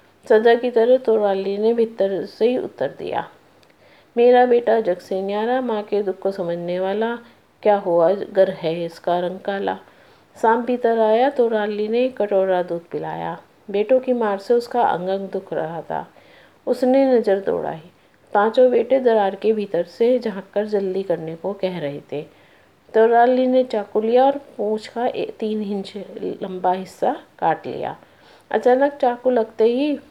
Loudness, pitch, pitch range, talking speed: -20 LUFS, 215 Hz, 195-240 Hz, 160 wpm